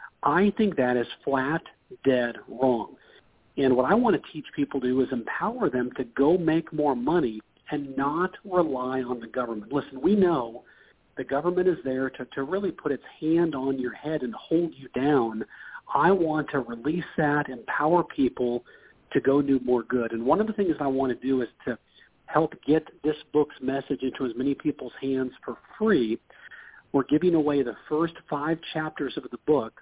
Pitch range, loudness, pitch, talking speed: 130-155 Hz, -26 LUFS, 140 Hz, 190 wpm